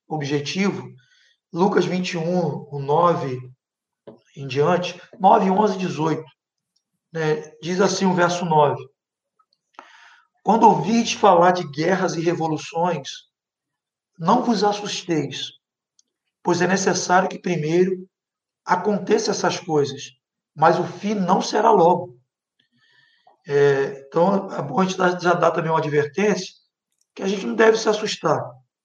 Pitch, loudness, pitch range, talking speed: 180 Hz, -20 LUFS, 155-200 Hz, 125 wpm